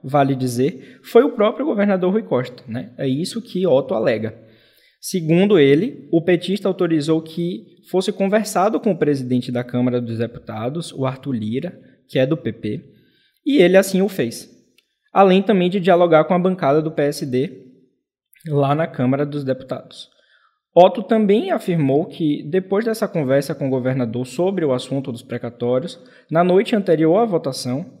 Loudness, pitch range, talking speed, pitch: -19 LUFS, 130-185 Hz, 160 wpm, 155 Hz